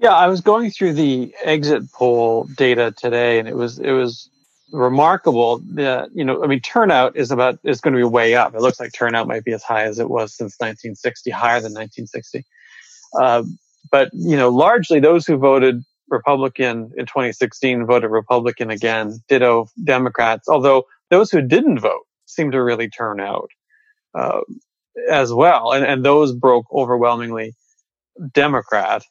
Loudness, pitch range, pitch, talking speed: -17 LUFS, 120-145 Hz, 125 Hz, 165 wpm